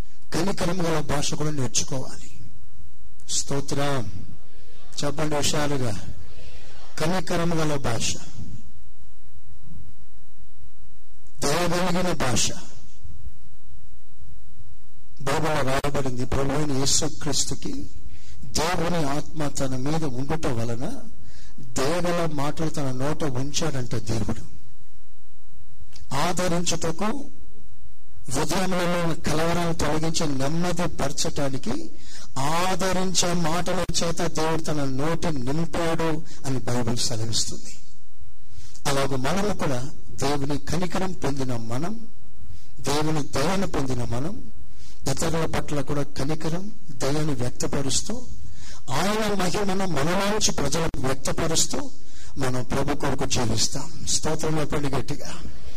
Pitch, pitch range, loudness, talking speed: 145 Hz, 125-165 Hz, -26 LUFS, 75 wpm